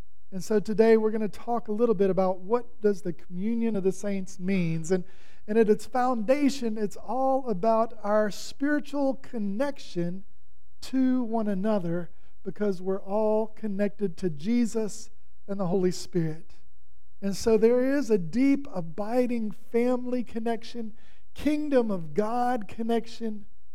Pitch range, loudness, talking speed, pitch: 195-235 Hz, -28 LUFS, 140 wpm, 215 Hz